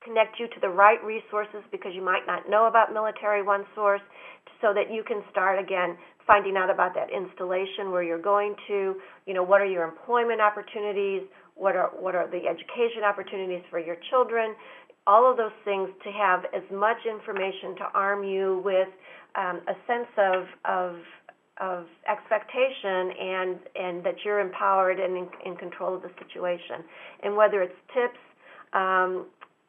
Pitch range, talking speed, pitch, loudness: 185-210 Hz, 170 wpm, 195 Hz, -26 LUFS